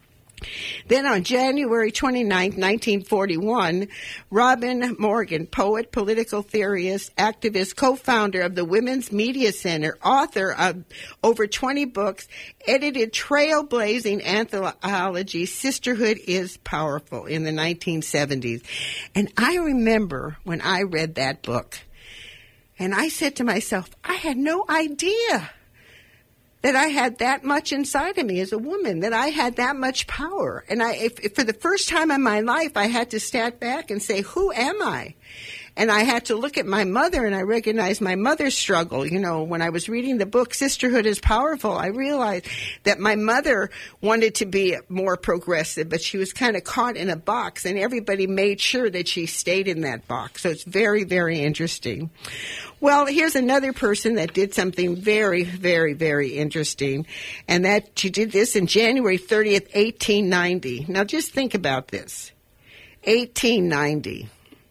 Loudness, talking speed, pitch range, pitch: -22 LUFS, 160 wpm, 180-245 Hz, 210 Hz